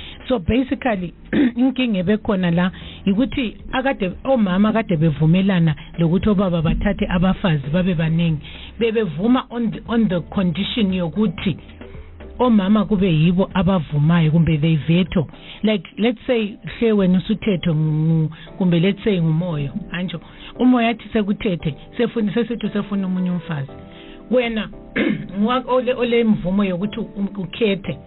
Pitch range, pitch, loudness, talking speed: 170-225 Hz, 195 Hz, -19 LUFS, 110 wpm